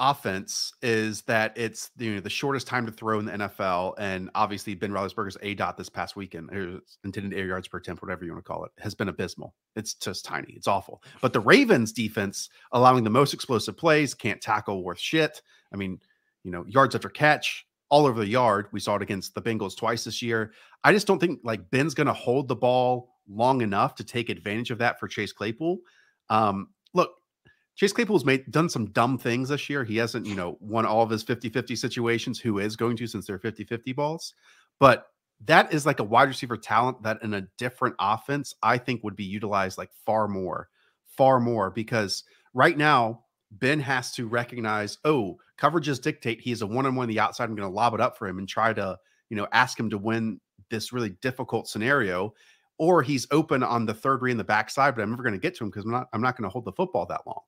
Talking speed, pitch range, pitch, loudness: 230 wpm, 105-130 Hz, 115 Hz, -26 LUFS